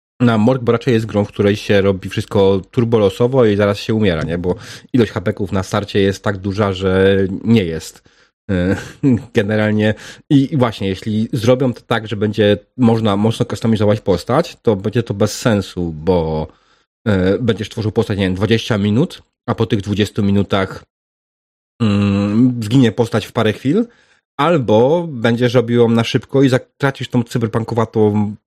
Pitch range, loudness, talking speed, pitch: 100-120 Hz, -16 LUFS, 160 wpm, 110 Hz